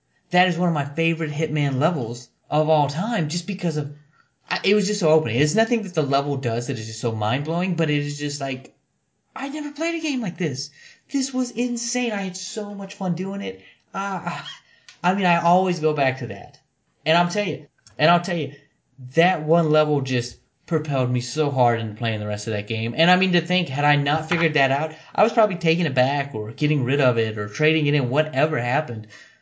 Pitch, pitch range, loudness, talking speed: 155 Hz, 135-180 Hz, -22 LUFS, 230 wpm